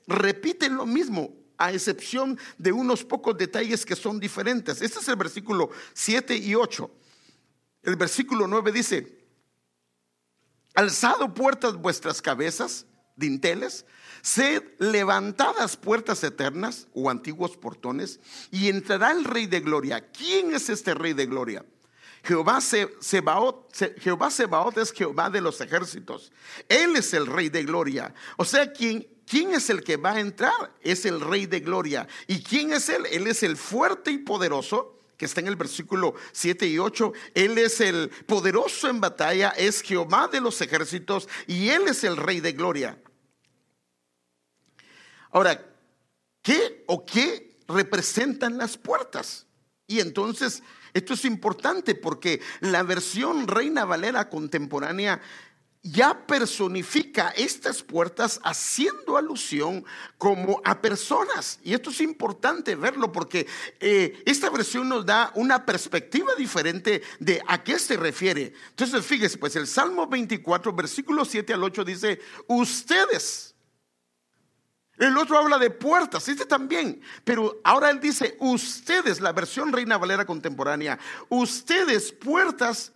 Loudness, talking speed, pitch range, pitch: -25 LUFS, 135 wpm, 185-265 Hz, 225 Hz